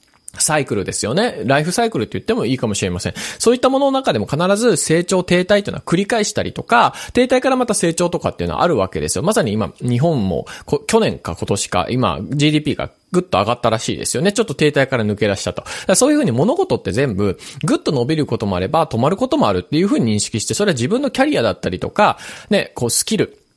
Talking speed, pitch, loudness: 495 characters per minute, 160 Hz, -17 LUFS